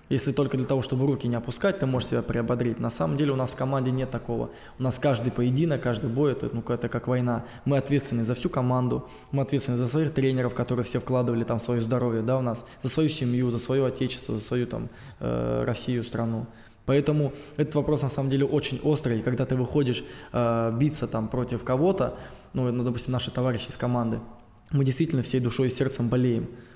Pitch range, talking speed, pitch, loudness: 120-135 Hz, 200 wpm, 125 Hz, -26 LUFS